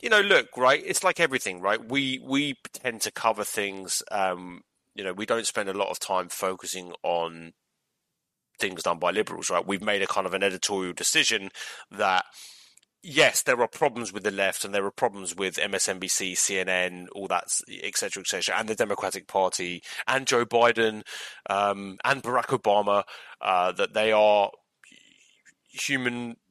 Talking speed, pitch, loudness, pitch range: 170 wpm, 100 Hz, -26 LUFS, 95-120 Hz